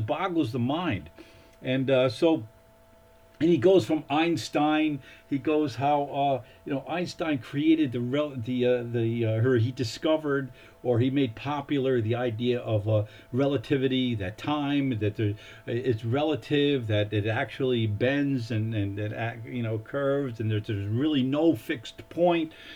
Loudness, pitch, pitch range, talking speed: -27 LUFS, 130 Hz, 115-145 Hz, 155 wpm